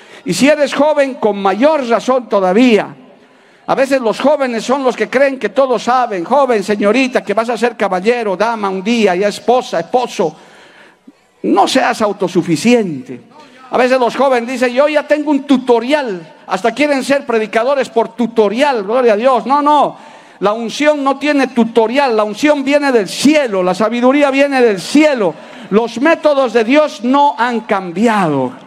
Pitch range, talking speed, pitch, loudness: 215-280 Hz, 165 wpm, 240 Hz, -13 LUFS